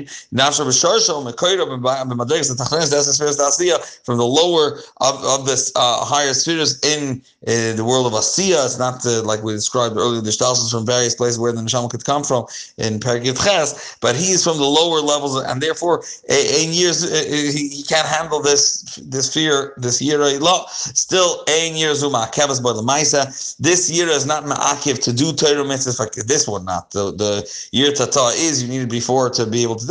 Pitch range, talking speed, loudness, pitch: 120-155 Hz, 165 wpm, -17 LUFS, 140 Hz